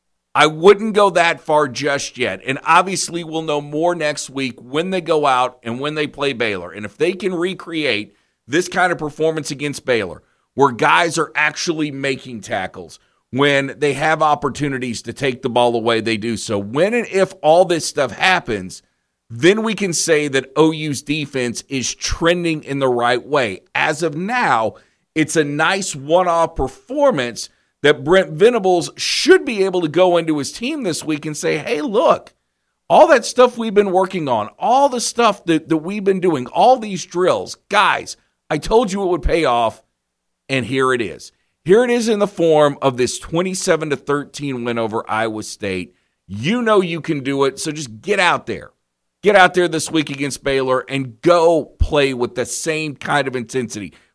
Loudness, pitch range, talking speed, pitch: -17 LUFS, 130-180 Hz, 190 wpm, 155 Hz